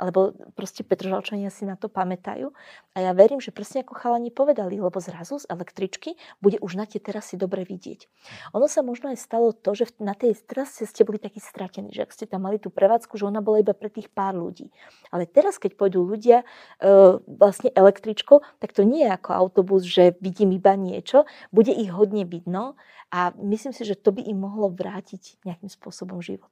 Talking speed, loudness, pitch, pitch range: 200 wpm, -22 LUFS, 205 Hz, 190-230 Hz